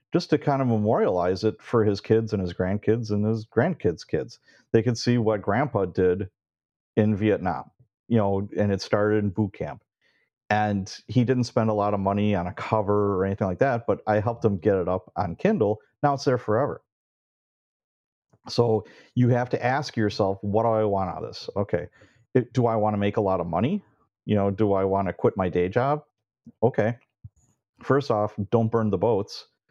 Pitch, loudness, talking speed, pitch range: 105 Hz, -25 LUFS, 205 wpm, 100-120 Hz